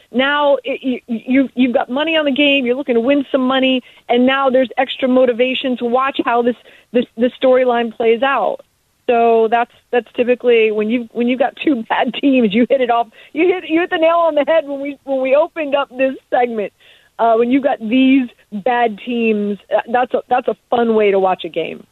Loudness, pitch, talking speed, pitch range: -16 LUFS, 255 Hz, 220 wpm, 235-275 Hz